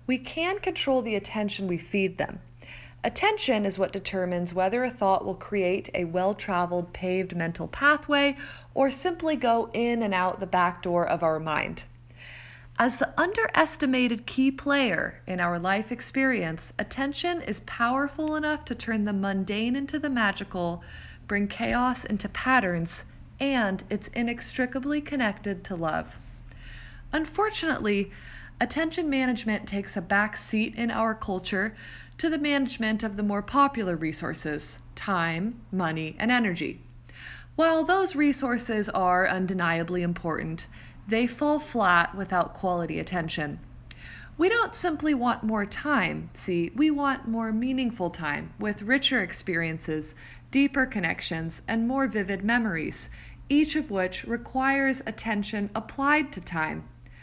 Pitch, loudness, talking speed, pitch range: 215 Hz, -27 LUFS, 135 wpm, 185-270 Hz